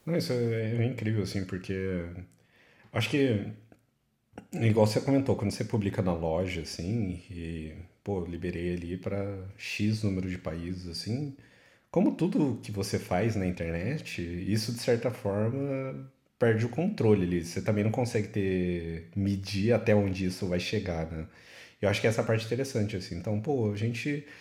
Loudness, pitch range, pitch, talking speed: -30 LUFS, 90-115 Hz, 100 Hz, 165 wpm